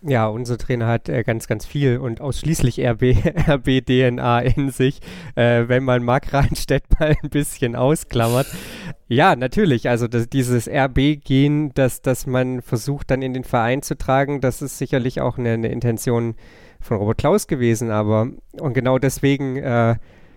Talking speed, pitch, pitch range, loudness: 160 wpm, 130 Hz, 120-140 Hz, -19 LUFS